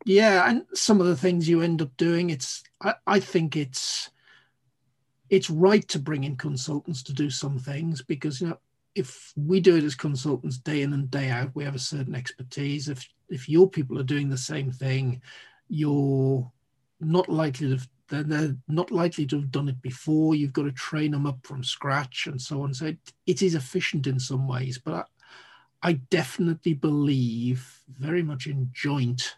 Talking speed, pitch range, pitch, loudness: 195 wpm, 135-165 Hz, 145 Hz, -26 LUFS